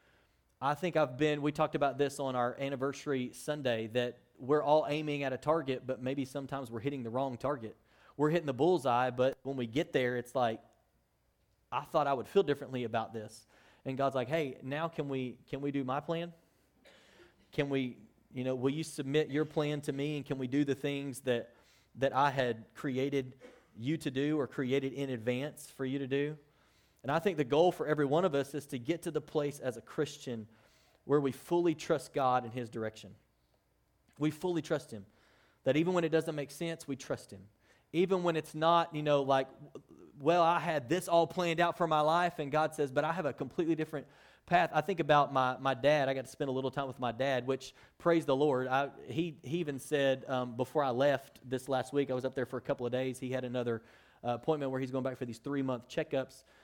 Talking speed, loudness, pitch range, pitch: 225 wpm, -34 LUFS, 130-150 Hz, 140 Hz